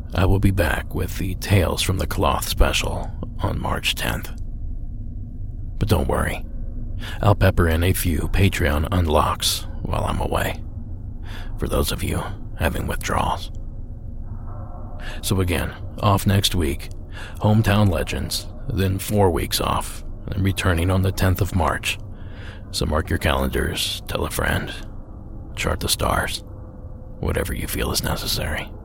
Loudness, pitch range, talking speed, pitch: -22 LUFS, 85-105 Hz, 135 wpm, 95 Hz